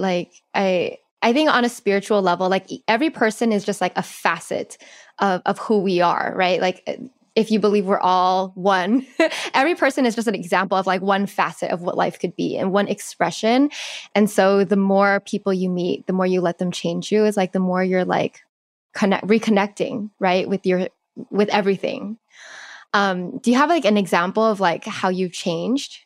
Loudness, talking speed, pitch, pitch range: -20 LUFS, 200 wpm, 200 Hz, 185-225 Hz